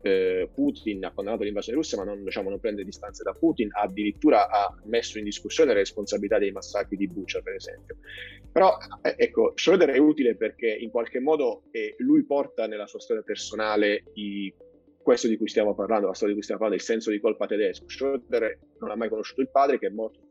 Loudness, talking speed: -26 LUFS, 205 wpm